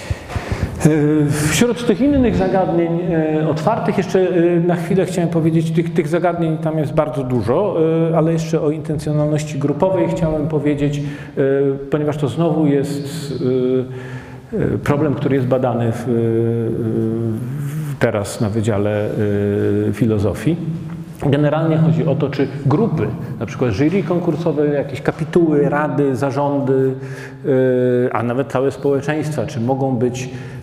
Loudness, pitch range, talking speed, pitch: -18 LUFS, 130-160 Hz, 115 wpm, 145 Hz